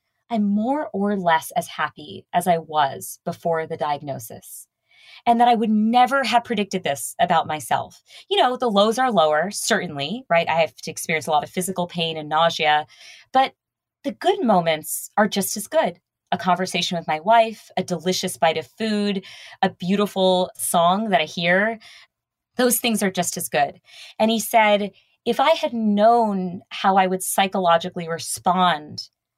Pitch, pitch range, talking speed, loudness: 190 Hz, 170-225 Hz, 170 wpm, -21 LUFS